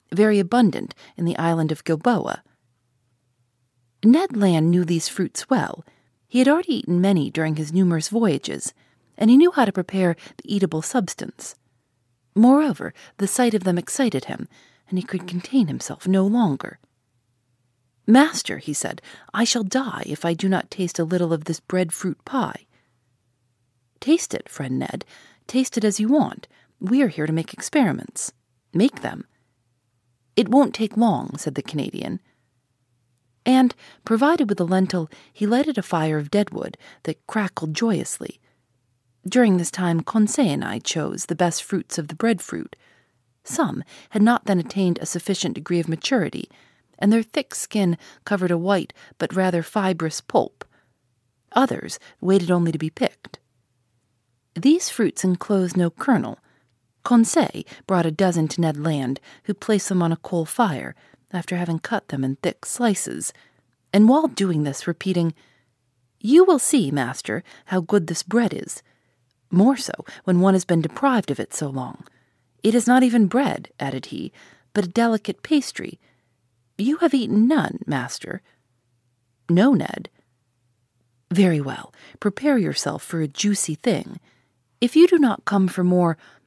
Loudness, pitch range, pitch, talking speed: -21 LUFS, 130-220 Hz, 175 Hz, 155 wpm